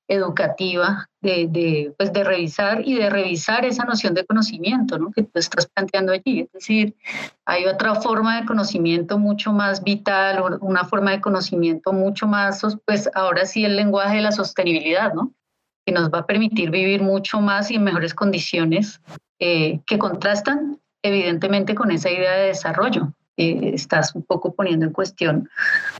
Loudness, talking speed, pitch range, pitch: -20 LUFS, 165 wpm, 175-210 Hz, 195 Hz